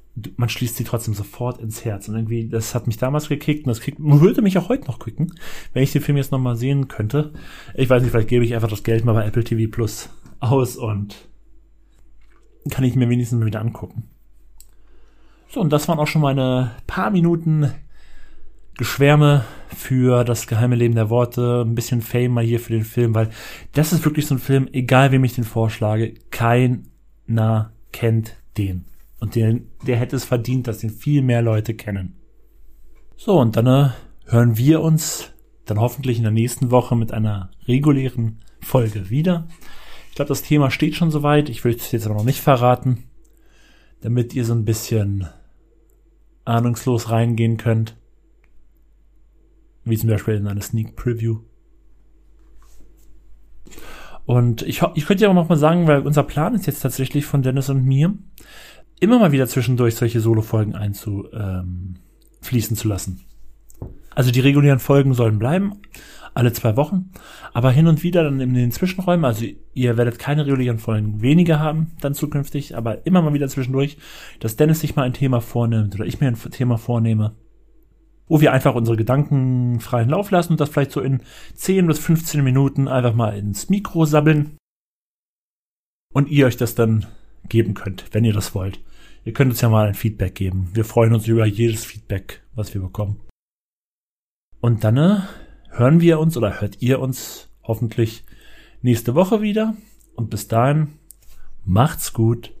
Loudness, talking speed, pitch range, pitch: -19 LUFS, 175 wpm, 110-140 Hz, 120 Hz